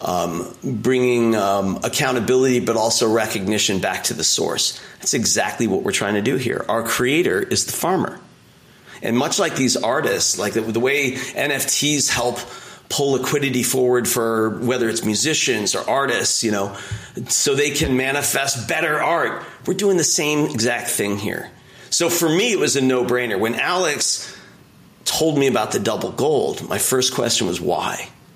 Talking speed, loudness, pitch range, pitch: 170 wpm, -19 LUFS, 115-140 Hz, 125 Hz